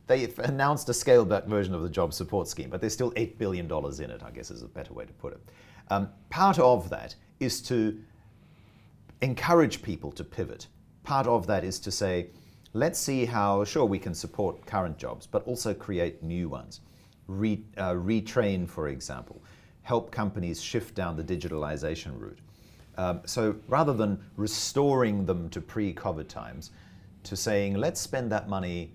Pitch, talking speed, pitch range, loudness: 100 Hz, 175 wpm, 90-115 Hz, -29 LUFS